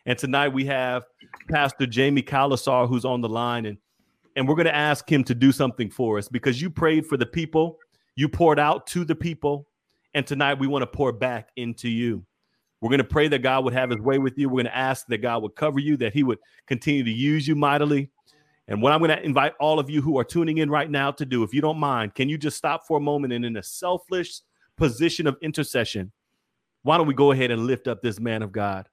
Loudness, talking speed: -23 LUFS, 250 wpm